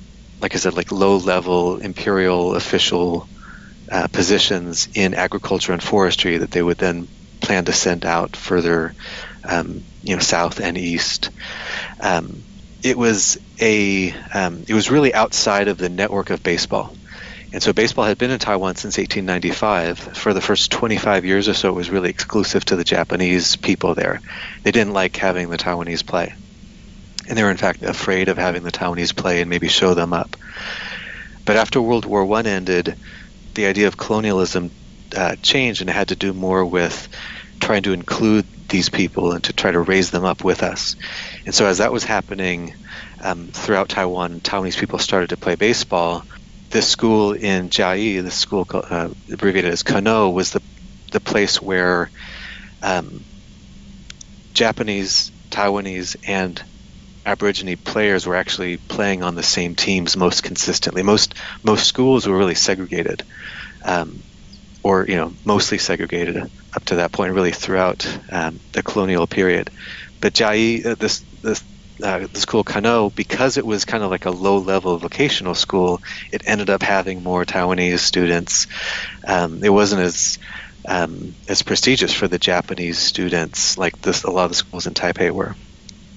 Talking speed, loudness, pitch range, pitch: 165 wpm, -18 LUFS, 90-100 Hz, 95 Hz